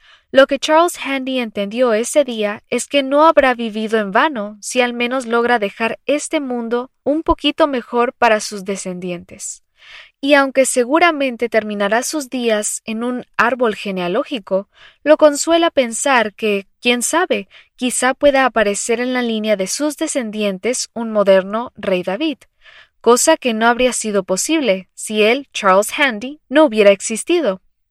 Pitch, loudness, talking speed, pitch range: 245 Hz, -16 LUFS, 150 wpm, 215-280 Hz